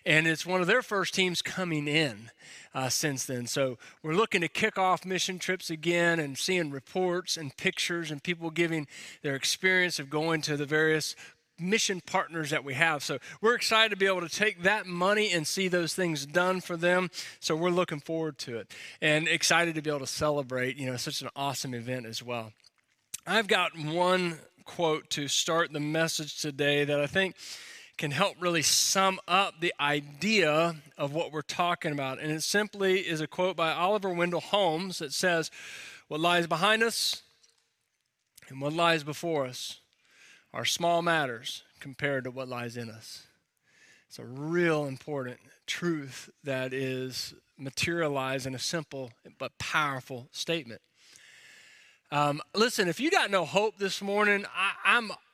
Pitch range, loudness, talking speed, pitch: 145-185 Hz, -28 LUFS, 170 wpm, 165 Hz